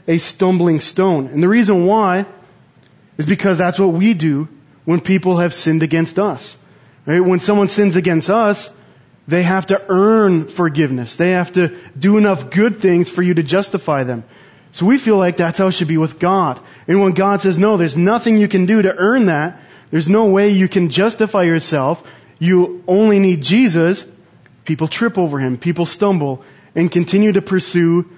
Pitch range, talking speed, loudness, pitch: 165-195 Hz, 185 wpm, -15 LUFS, 180 Hz